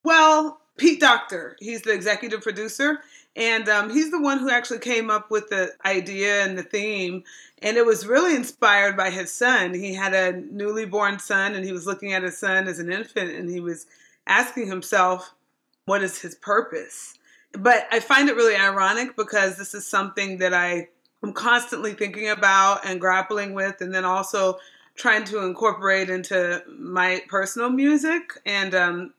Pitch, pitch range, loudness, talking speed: 200 Hz, 190-235 Hz, -21 LUFS, 175 wpm